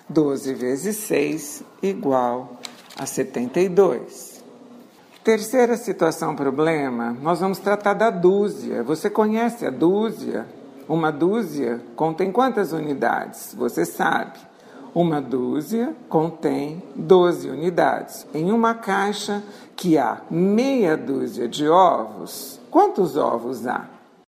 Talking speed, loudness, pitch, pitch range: 105 wpm, -21 LUFS, 175 Hz, 145-205 Hz